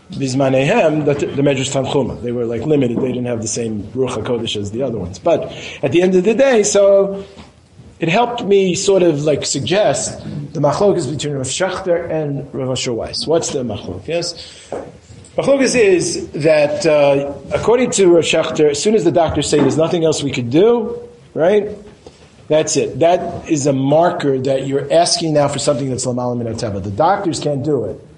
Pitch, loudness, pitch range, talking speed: 150 Hz, -16 LUFS, 135-180 Hz, 185 wpm